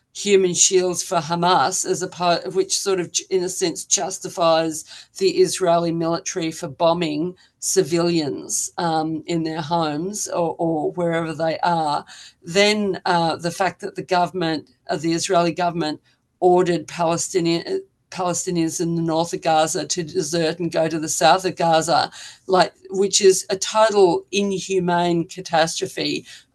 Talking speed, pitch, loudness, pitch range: 145 wpm, 175 Hz, -20 LUFS, 165-185 Hz